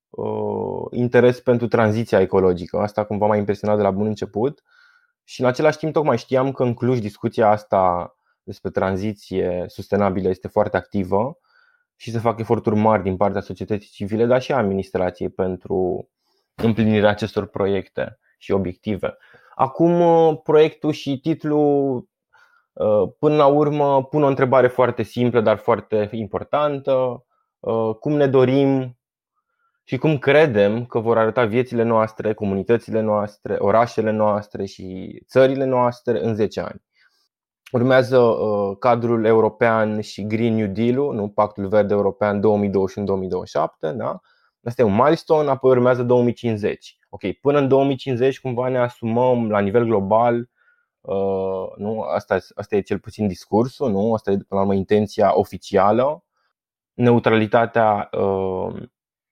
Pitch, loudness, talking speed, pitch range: 115 Hz, -20 LUFS, 135 wpm, 105-135 Hz